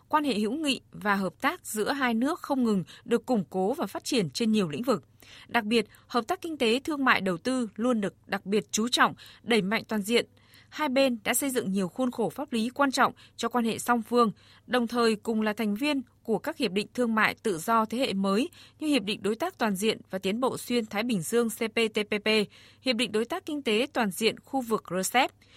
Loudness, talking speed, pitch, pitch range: -28 LUFS, 240 wpm, 230 Hz, 215-255 Hz